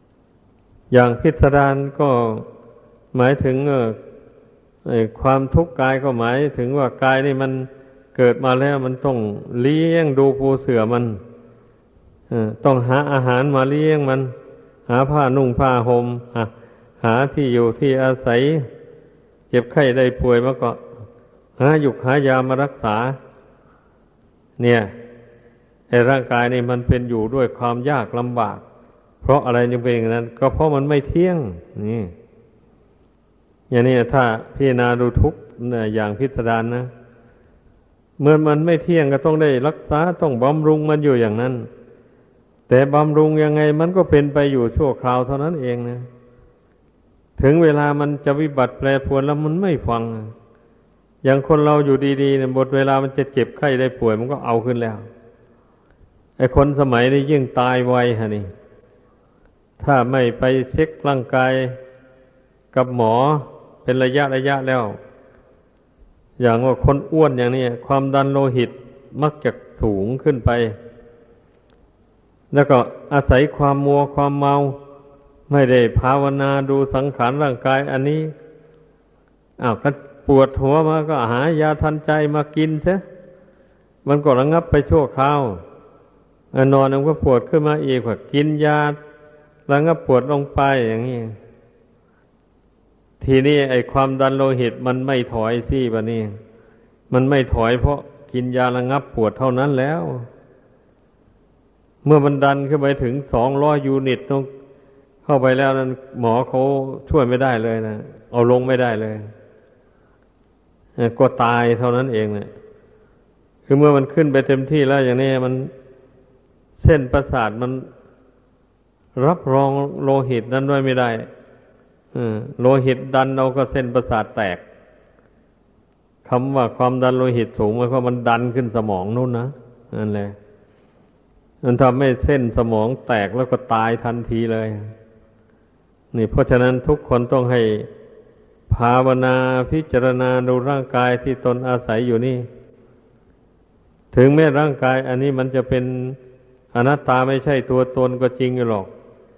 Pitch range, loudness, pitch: 120-140 Hz, -18 LUFS, 130 Hz